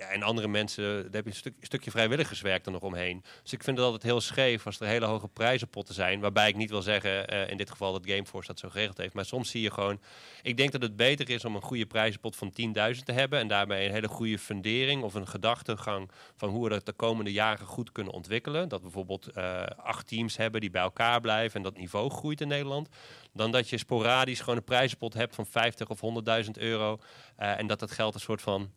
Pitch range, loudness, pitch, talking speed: 100-120 Hz, -30 LUFS, 110 Hz, 250 wpm